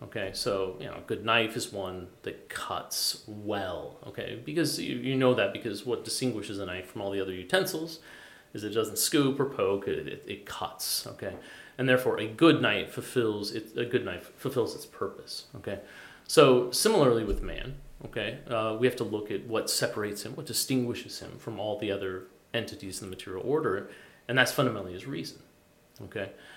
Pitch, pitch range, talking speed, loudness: 115 Hz, 100-130 Hz, 190 wpm, -30 LUFS